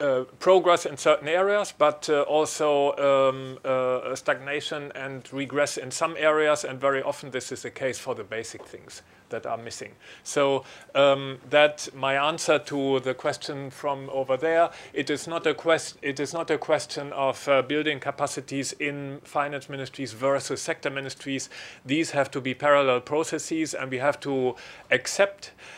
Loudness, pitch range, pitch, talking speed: -26 LUFS, 135-155 Hz, 140 Hz, 165 wpm